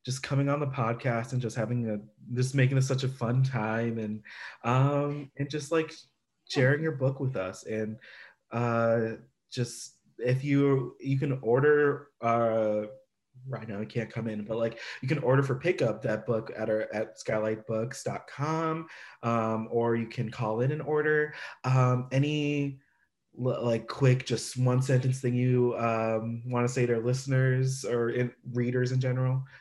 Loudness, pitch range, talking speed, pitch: -29 LUFS, 115-135 Hz, 170 wpm, 125 Hz